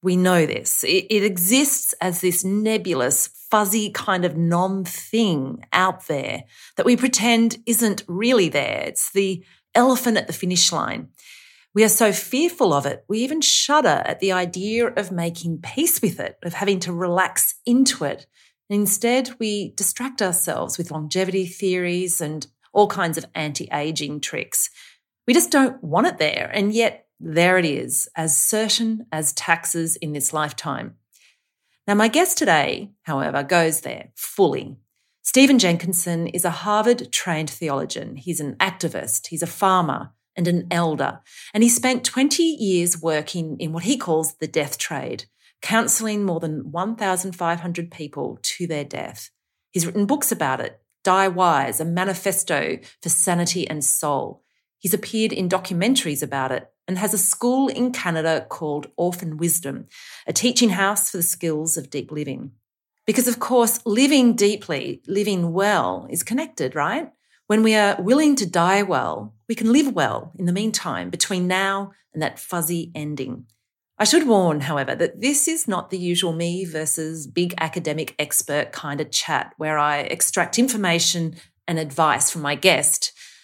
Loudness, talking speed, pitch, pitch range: -20 LUFS, 160 wpm, 185 Hz, 165-220 Hz